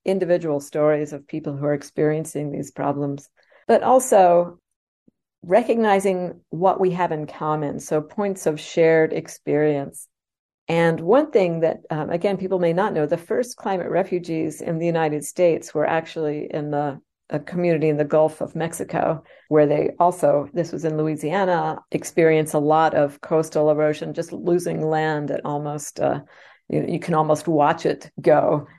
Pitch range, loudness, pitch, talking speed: 150-175 Hz, -21 LUFS, 160 Hz, 165 wpm